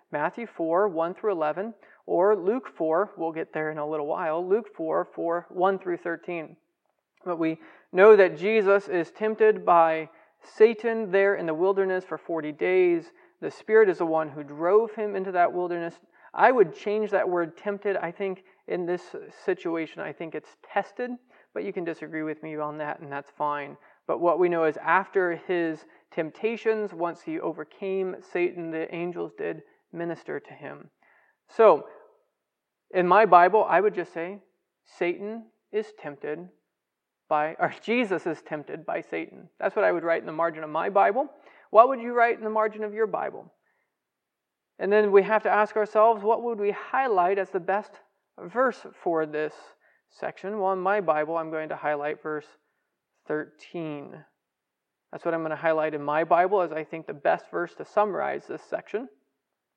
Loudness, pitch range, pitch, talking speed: -26 LUFS, 160-210 Hz, 180 Hz, 180 wpm